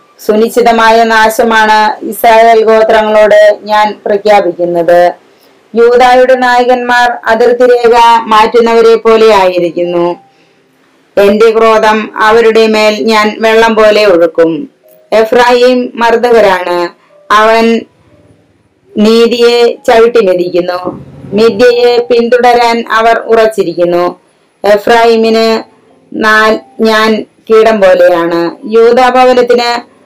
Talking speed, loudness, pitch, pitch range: 75 wpm, -6 LUFS, 225 Hz, 210-235 Hz